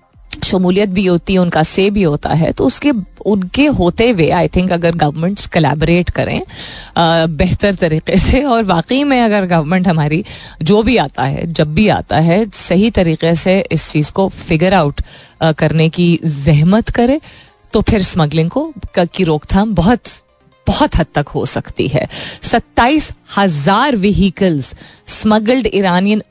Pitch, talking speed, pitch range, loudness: 180 Hz, 155 wpm, 160-205 Hz, -13 LUFS